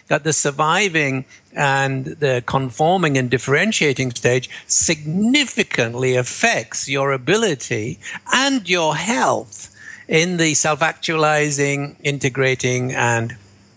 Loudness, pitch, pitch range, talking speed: -18 LUFS, 140 Hz, 130-160 Hz, 95 wpm